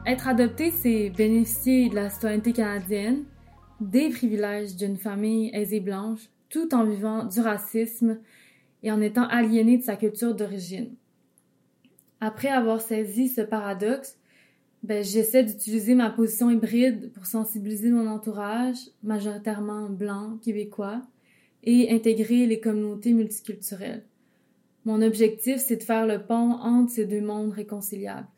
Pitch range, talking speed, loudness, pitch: 215-240 Hz, 130 wpm, -25 LUFS, 225 Hz